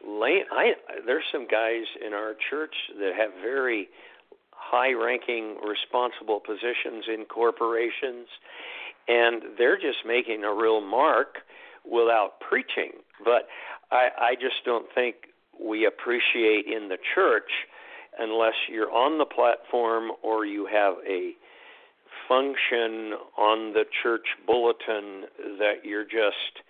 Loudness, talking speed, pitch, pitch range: -26 LUFS, 120 wpm, 115 Hz, 110-120 Hz